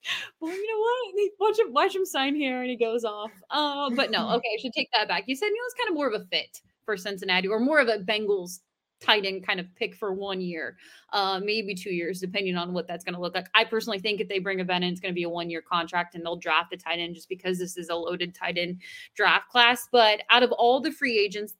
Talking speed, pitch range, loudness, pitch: 270 wpm, 180-250 Hz, -26 LUFS, 210 Hz